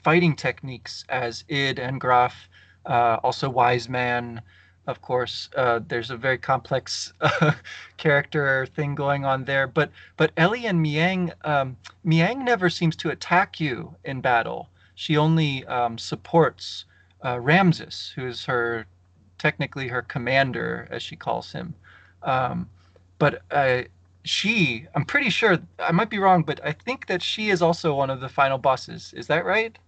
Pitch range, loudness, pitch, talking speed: 120-160 Hz, -23 LUFS, 135 Hz, 160 wpm